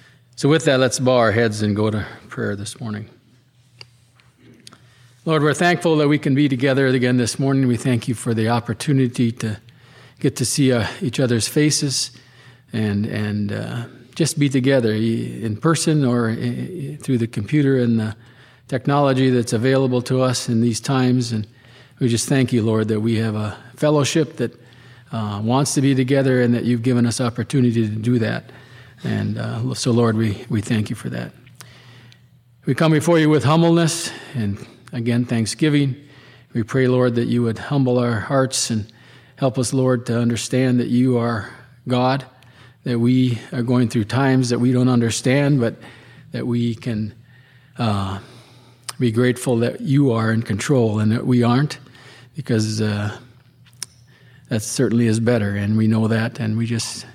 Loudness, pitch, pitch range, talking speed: -19 LUFS, 125 Hz, 115-130 Hz, 170 wpm